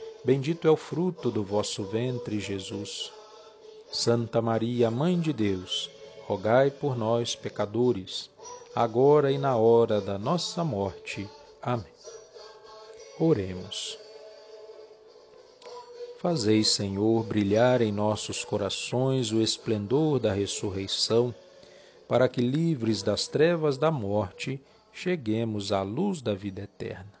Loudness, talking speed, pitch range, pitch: -27 LUFS, 110 wpm, 105-175 Hz, 125 Hz